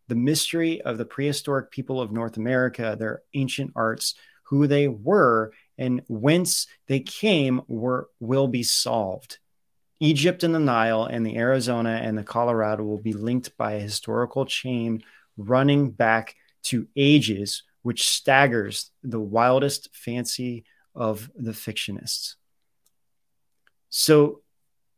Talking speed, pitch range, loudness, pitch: 125 wpm, 115-140 Hz, -24 LUFS, 125 Hz